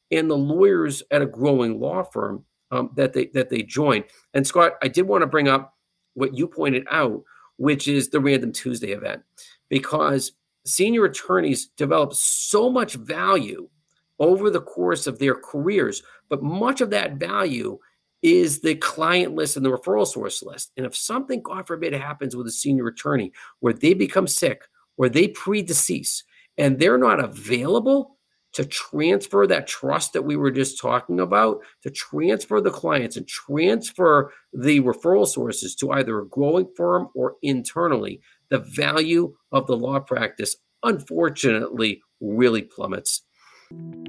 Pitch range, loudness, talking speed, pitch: 130-180 Hz, -21 LUFS, 155 wpm, 145 Hz